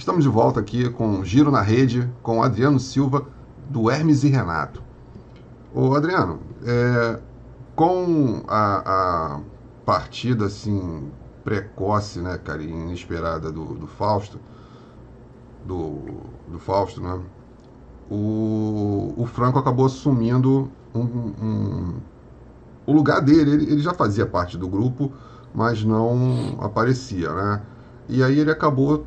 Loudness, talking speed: -21 LUFS, 120 wpm